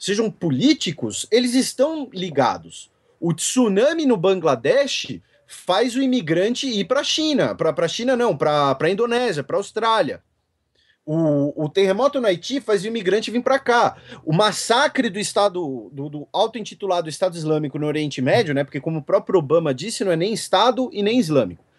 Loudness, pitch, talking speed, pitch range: -20 LUFS, 200 Hz, 175 wpm, 160-245 Hz